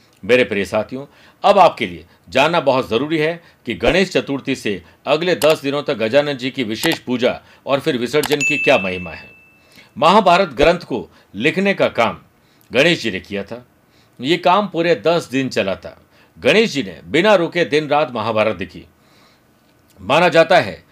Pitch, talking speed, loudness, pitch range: 140 Hz, 170 wpm, -16 LUFS, 110-160 Hz